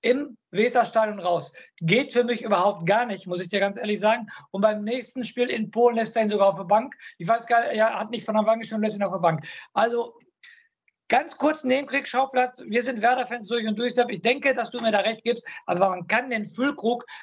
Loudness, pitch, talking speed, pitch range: -24 LUFS, 230 Hz, 230 wpm, 210-245 Hz